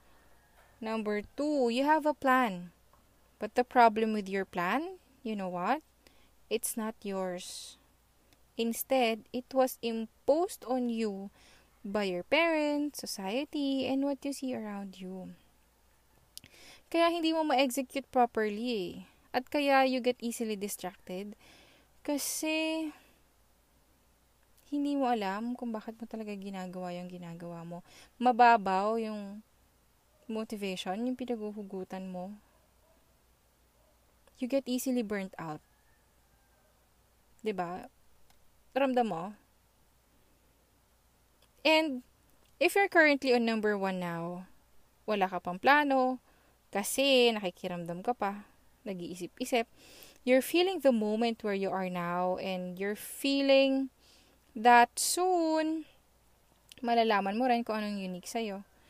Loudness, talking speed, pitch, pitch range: -31 LUFS, 110 wpm, 230 Hz, 195-265 Hz